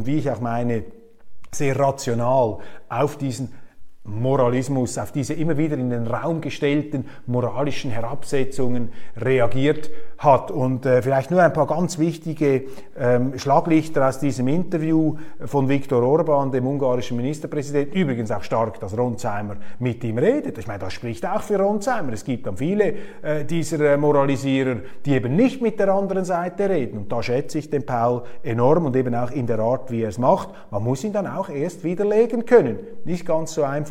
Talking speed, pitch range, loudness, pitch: 180 wpm, 125-160 Hz, -22 LUFS, 140 Hz